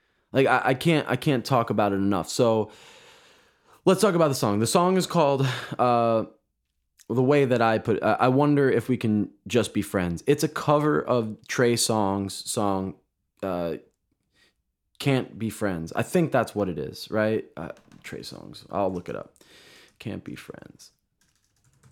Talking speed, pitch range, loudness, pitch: 175 wpm, 100-140 Hz, -24 LUFS, 115 Hz